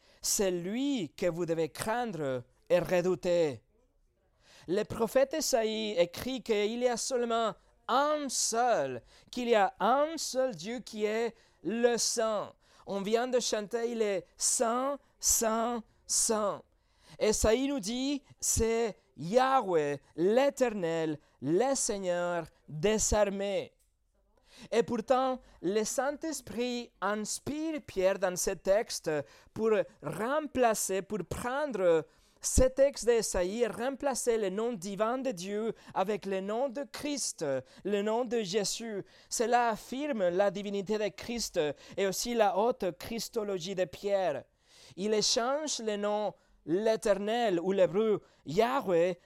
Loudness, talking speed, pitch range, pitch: -31 LUFS, 125 wpm, 195-245 Hz, 220 Hz